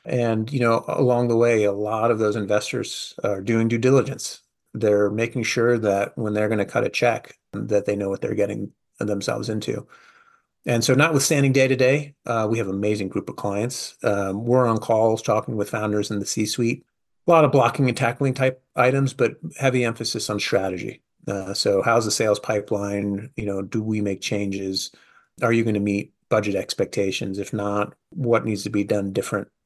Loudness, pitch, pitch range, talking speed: -22 LUFS, 115 Hz, 105-125 Hz, 195 wpm